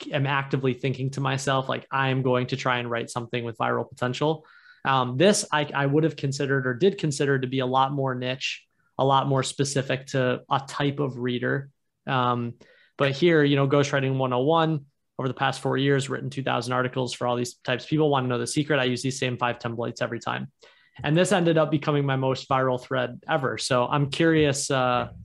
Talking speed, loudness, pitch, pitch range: 210 wpm, -25 LUFS, 135 Hz, 125-145 Hz